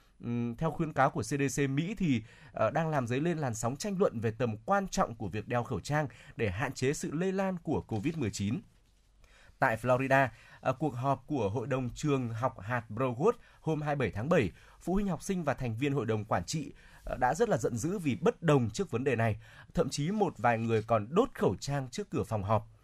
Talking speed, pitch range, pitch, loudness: 220 wpm, 115-155 Hz, 135 Hz, -32 LUFS